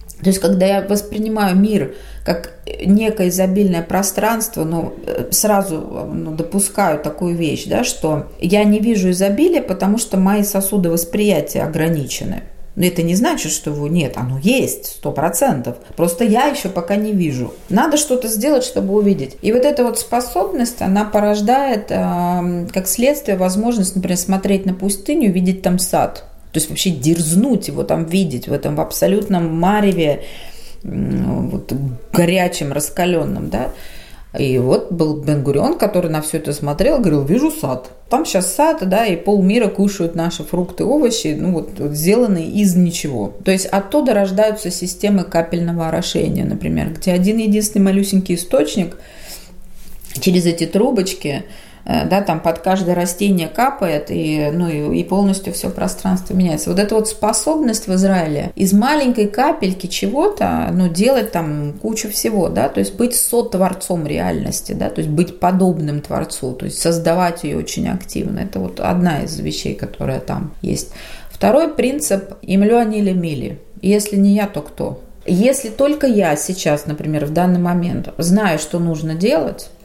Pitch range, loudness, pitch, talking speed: 165-210 Hz, -17 LUFS, 190 Hz, 155 wpm